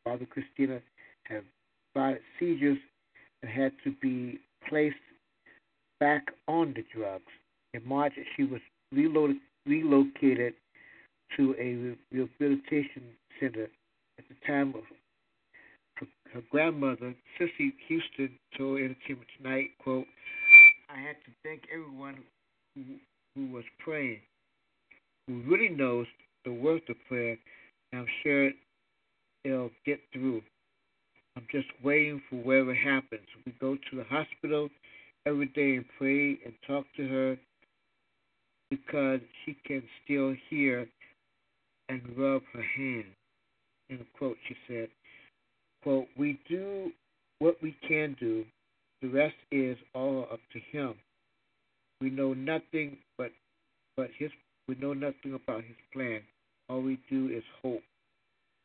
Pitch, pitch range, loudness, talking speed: 135 Hz, 125-145 Hz, -28 LUFS, 125 wpm